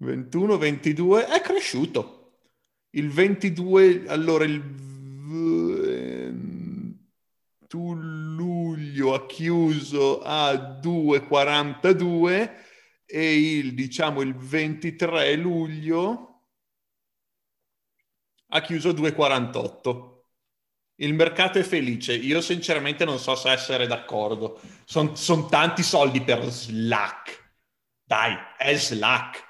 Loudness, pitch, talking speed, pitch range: -23 LUFS, 155 Hz, 90 wpm, 135-170 Hz